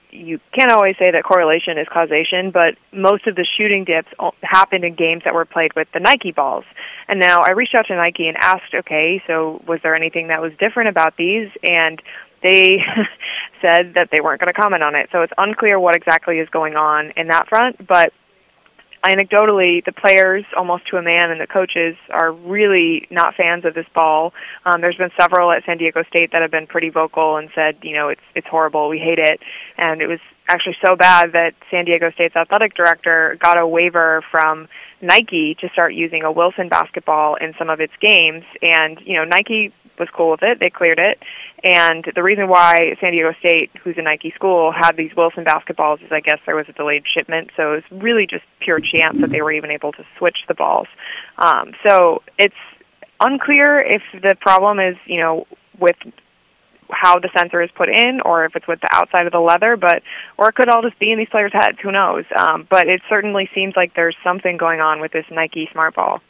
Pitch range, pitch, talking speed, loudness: 160-190 Hz, 170 Hz, 215 wpm, -15 LUFS